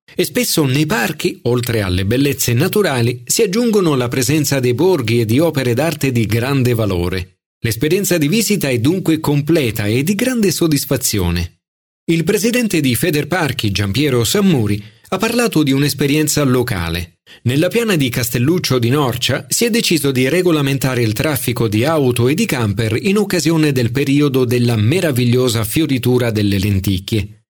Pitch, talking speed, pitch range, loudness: 135 Hz, 150 wpm, 115-165 Hz, -15 LUFS